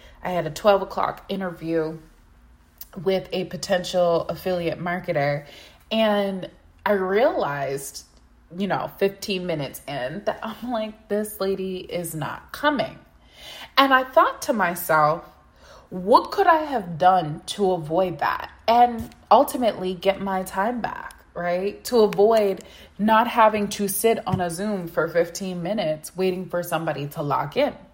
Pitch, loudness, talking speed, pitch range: 185 Hz, -23 LUFS, 140 wpm, 165-210 Hz